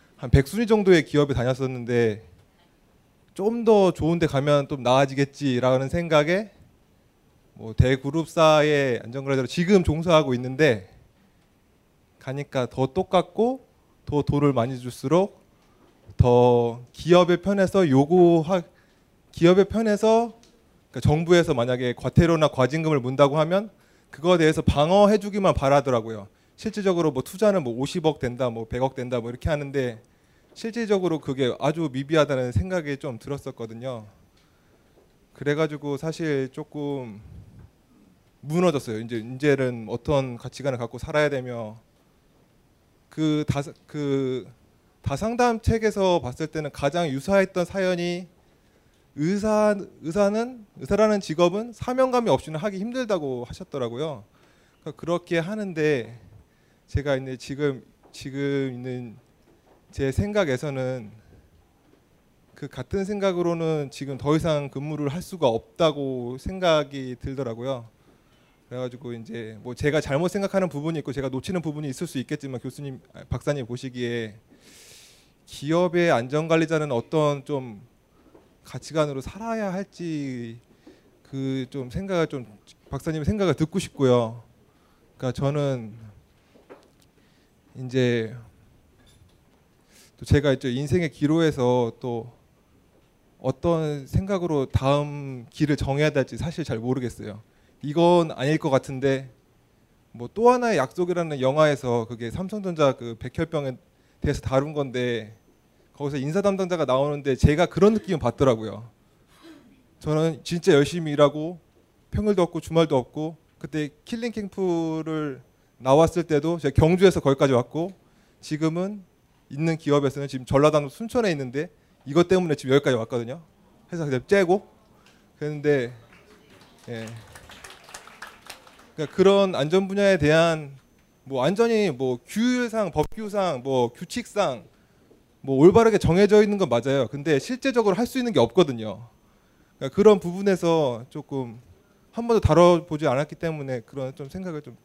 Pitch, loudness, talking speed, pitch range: 145 Hz, -23 LUFS, 285 characters per minute, 125-175 Hz